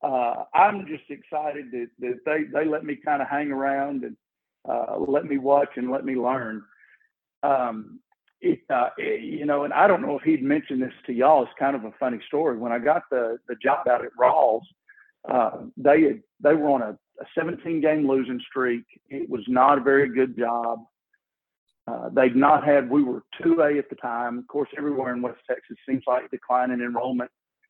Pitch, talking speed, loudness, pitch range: 140 Hz, 200 wpm, -24 LUFS, 125-150 Hz